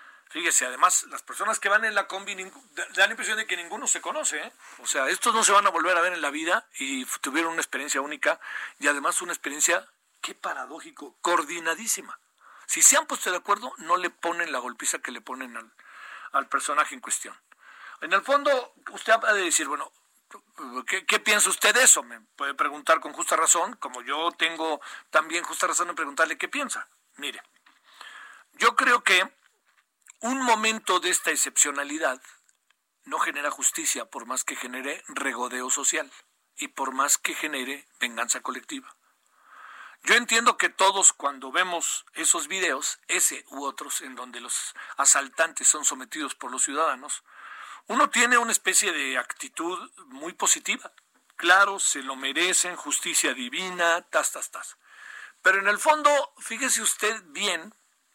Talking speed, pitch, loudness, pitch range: 165 wpm, 195 Hz, -24 LUFS, 165-255 Hz